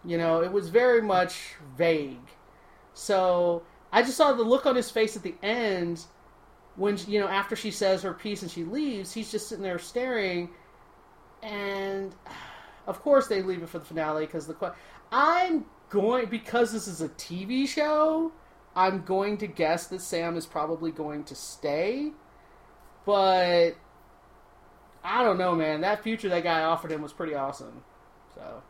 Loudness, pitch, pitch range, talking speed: -27 LUFS, 190 Hz, 170-220 Hz, 165 wpm